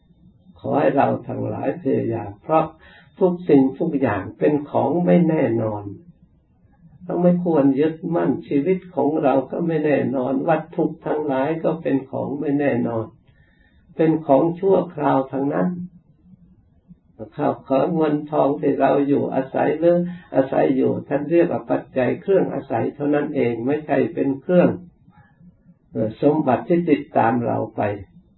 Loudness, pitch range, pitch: -20 LUFS, 135-170 Hz, 150 Hz